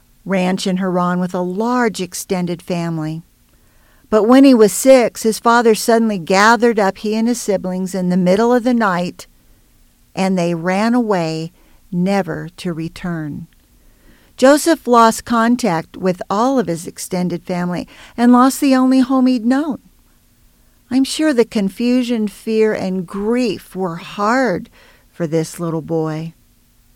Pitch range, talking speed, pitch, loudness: 175-240 Hz, 140 wpm, 195 Hz, -16 LUFS